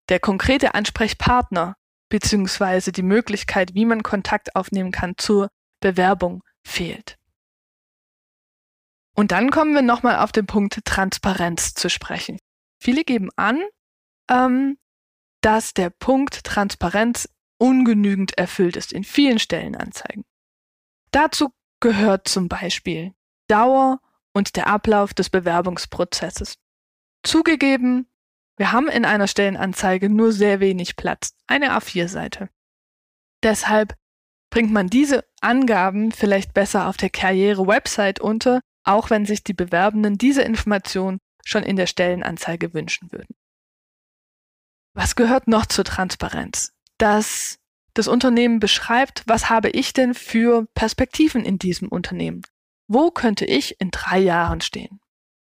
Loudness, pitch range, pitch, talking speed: -19 LUFS, 195-240 Hz, 210 Hz, 120 wpm